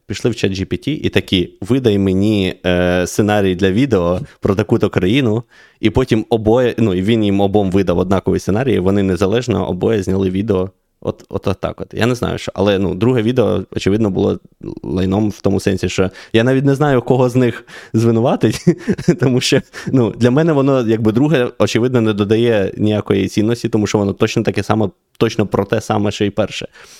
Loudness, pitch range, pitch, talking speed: -16 LUFS, 95-120 Hz, 105 Hz, 190 wpm